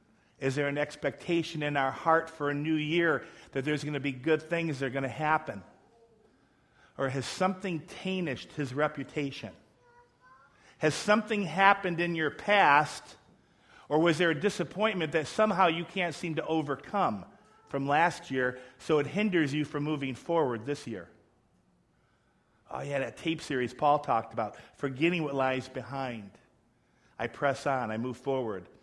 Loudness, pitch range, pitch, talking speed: -30 LUFS, 135-170 Hz, 150 Hz, 160 wpm